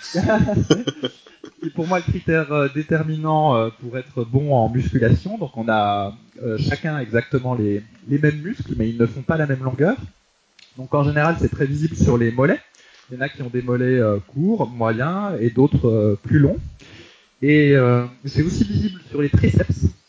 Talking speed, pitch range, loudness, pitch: 175 wpm, 115-150 Hz, -20 LUFS, 130 Hz